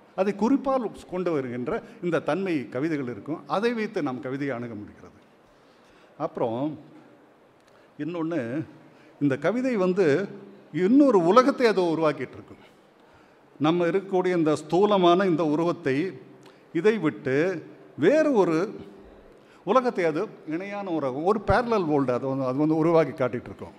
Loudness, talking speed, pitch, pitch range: -25 LUFS, 115 wpm, 165 Hz, 145-205 Hz